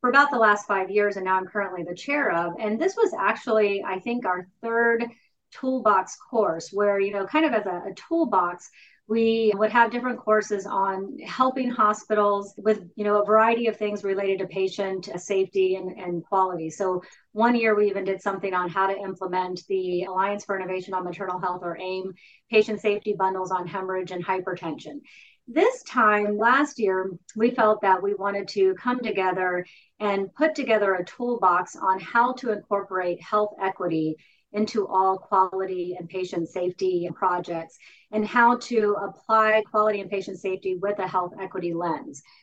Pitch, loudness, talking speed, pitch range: 195 Hz, -24 LUFS, 175 wpm, 185-215 Hz